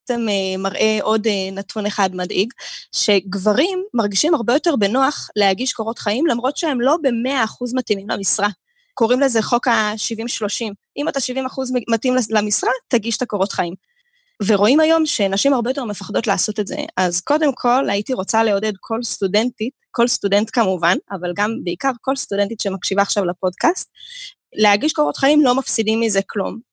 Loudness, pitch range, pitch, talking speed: -18 LUFS, 205-265 Hz, 225 Hz, 155 wpm